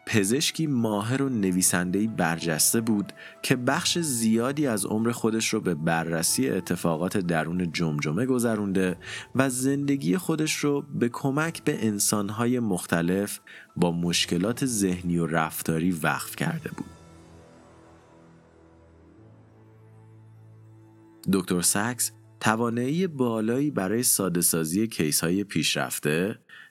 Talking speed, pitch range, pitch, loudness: 105 wpm, 85-120 Hz, 105 Hz, -25 LUFS